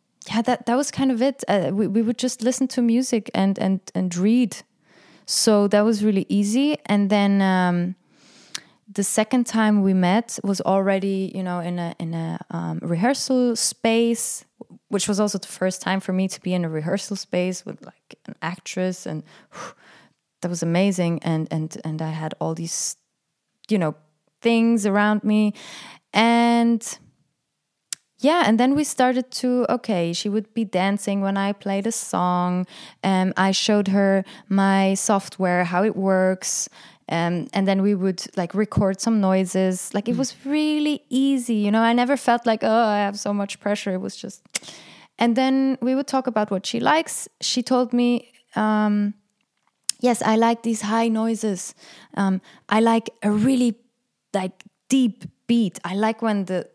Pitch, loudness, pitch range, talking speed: 205 Hz, -22 LUFS, 190-235 Hz, 175 wpm